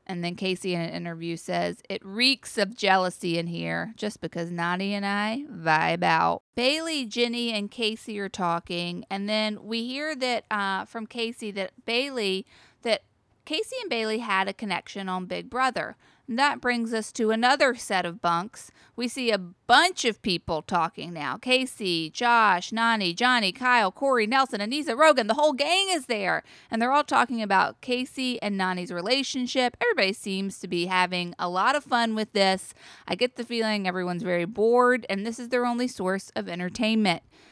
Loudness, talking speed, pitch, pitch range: -26 LUFS, 180 wpm, 215 Hz, 185-245 Hz